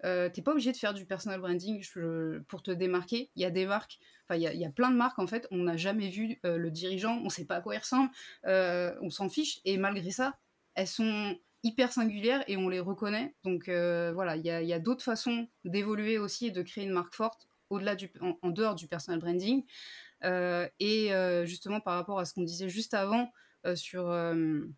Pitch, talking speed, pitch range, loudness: 190 Hz, 235 wpm, 175-220 Hz, -33 LUFS